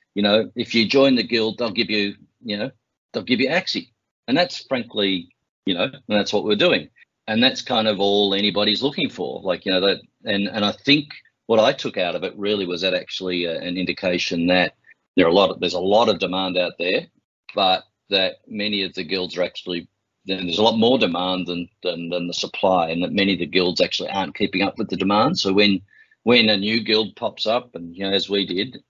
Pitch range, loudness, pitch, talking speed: 90-110 Hz, -20 LUFS, 100 Hz, 235 wpm